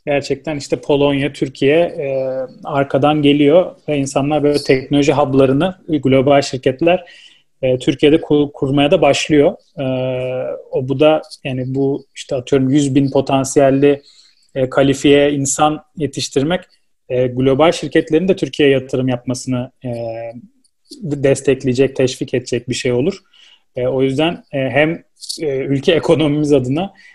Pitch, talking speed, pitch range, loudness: 140 Hz, 130 wpm, 135-150 Hz, -16 LUFS